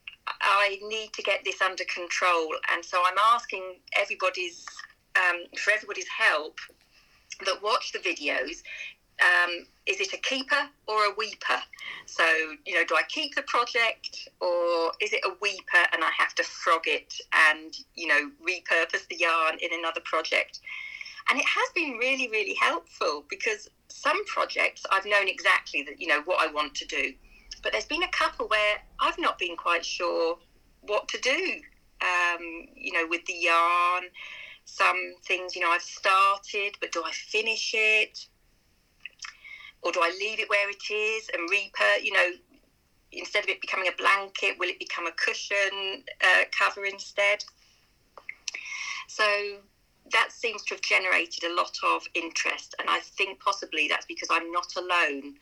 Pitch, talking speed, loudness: 200 Hz, 165 wpm, -26 LUFS